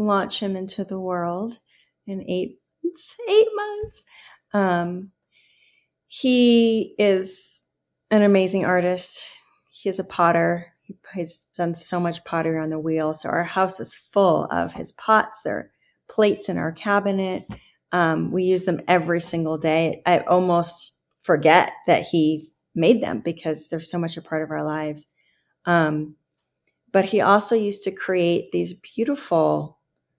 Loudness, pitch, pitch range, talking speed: -22 LUFS, 180 Hz, 165-200 Hz, 145 wpm